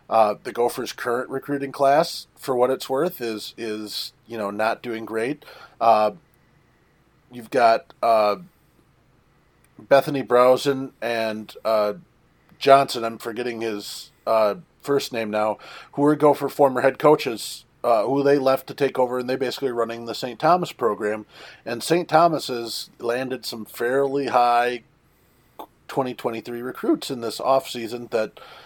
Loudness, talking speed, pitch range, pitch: -22 LUFS, 145 wpm, 115-140 Hz, 125 Hz